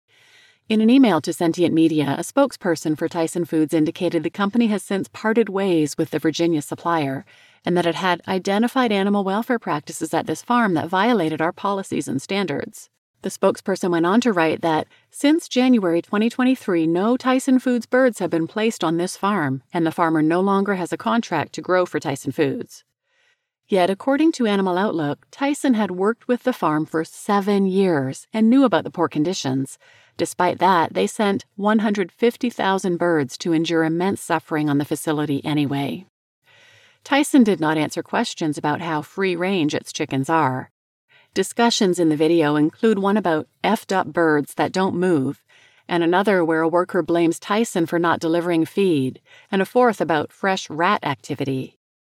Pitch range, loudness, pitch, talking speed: 160-220 Hz, -20 LUFS, 175 Hz, 170 wpm